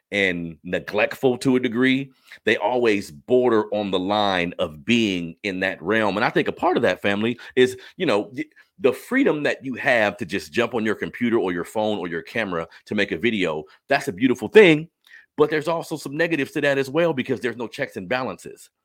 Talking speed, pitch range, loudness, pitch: 215 wpm, 105-140 Hz, -22 LUFS, 125 Hz